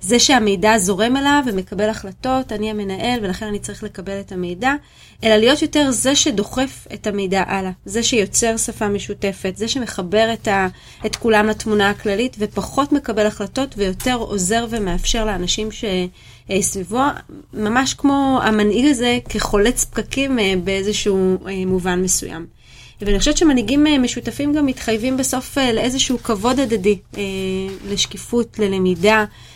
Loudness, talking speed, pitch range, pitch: -18 LUFS, 130 wpm, 195-250 Hz, 215 Hz